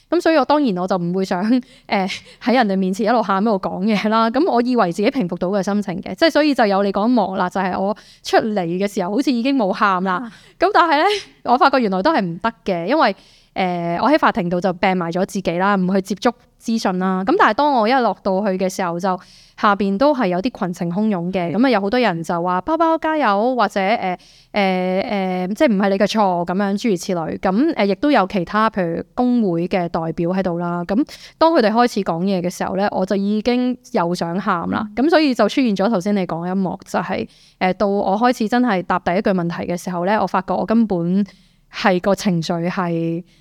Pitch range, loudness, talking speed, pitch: 185-235 Hz, -18 LUFS, 330 characters per minute, 200 Hz